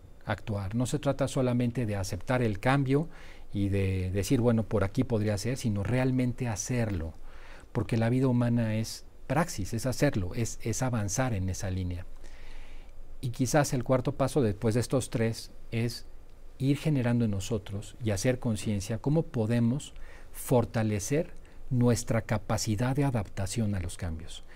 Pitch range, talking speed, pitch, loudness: 100-125 Hz, 150 wpm, 115 Hz, -30 LUFS